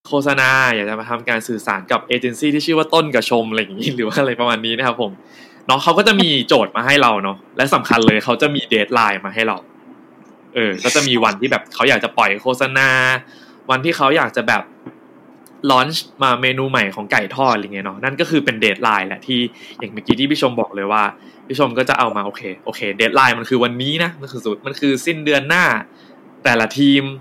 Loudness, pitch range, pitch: -16 LUFS, 110-140 Hz, 130 Hz